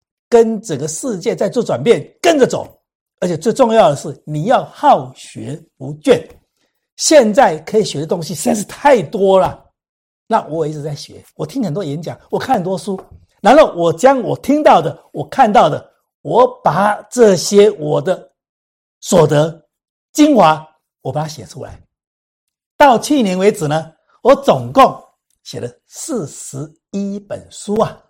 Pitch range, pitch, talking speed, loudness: 150-215 Hz, 170 Hz, 215 characters per minute, -14 LUFS